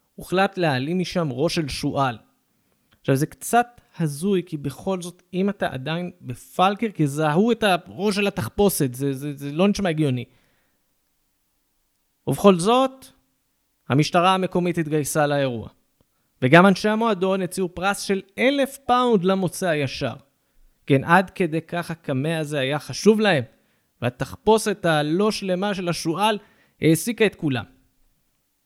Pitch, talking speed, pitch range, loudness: 175 Hz, 130 wpm, 145-200 Hz, -22 LUFS